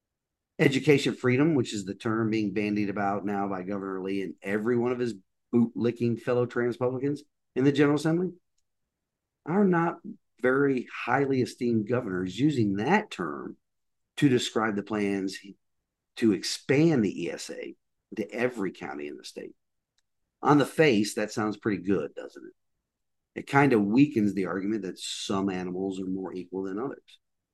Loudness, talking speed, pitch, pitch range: -27 LUFS, 155 wpm, 110 Hz, 100-135 Hz